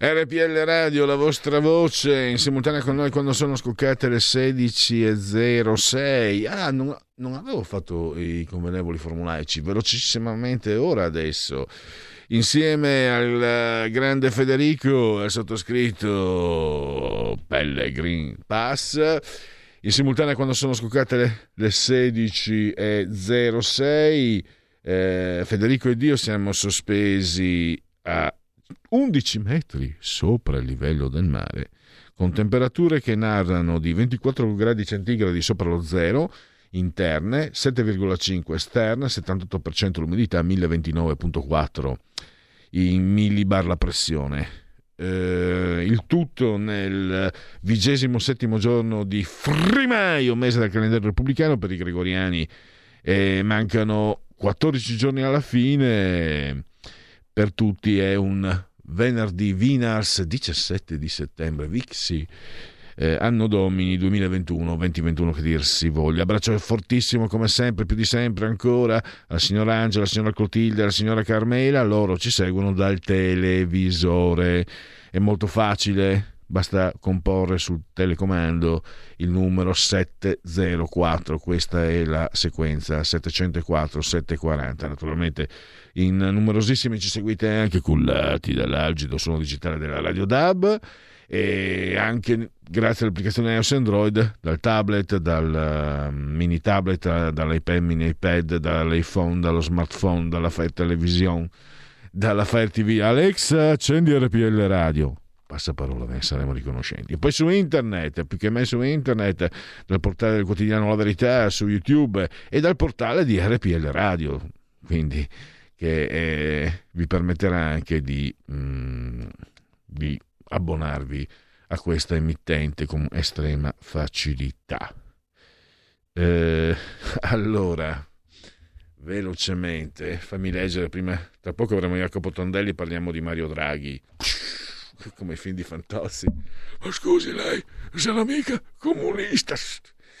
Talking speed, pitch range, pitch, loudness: 115 wpm, 85-115 Hz, 95 Hz, -22 LUFS